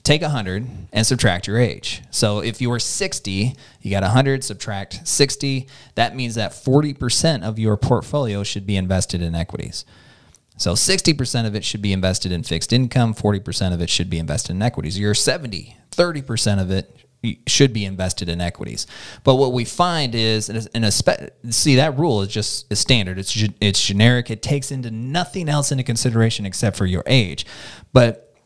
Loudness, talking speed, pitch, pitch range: -19 LUFS, 185 wpm, 115 Hz, 100-130 Hz